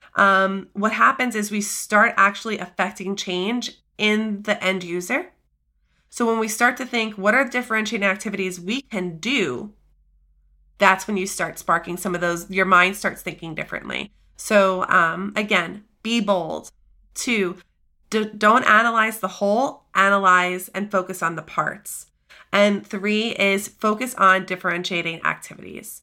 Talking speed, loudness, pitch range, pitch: 145 wpm, -20 LUFS, 180-215 Hz, 195 Hz